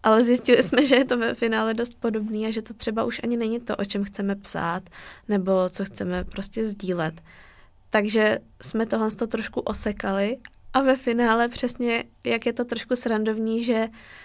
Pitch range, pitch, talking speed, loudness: 205-235 Hz, 225 Hz, 185 wpm, -24 LUFS